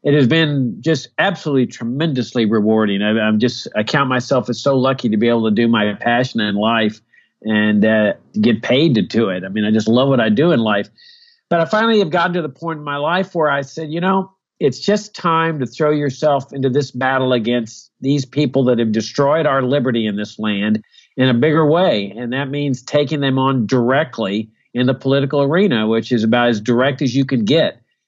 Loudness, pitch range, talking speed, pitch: -16 LUFS, 115-150 Hz, 220 wpm, 130 Hz